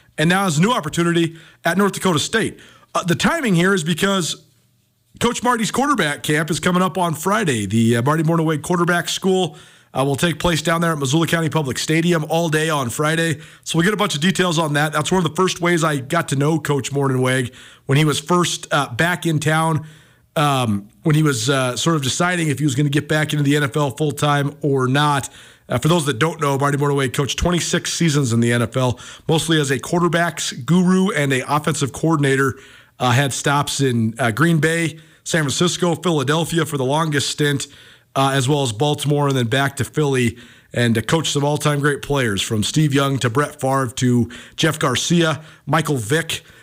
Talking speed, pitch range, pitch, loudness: 210 wpm, 135-170 Hz, 150 Hz, -18 LUFS